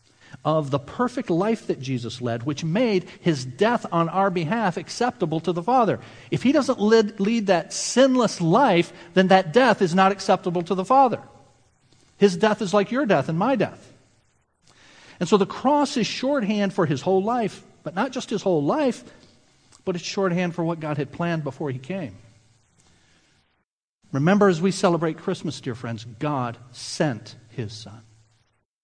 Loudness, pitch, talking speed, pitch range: -22 LUFS, 180 Hz, 170 wpm, 140-210 Hz